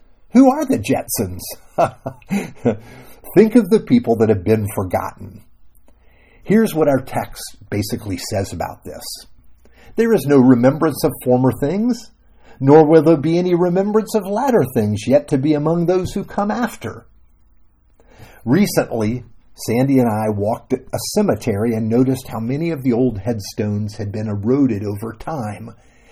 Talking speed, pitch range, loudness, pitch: 150 wpm, 110-180 Hz, -17 LUFS, 130 Hz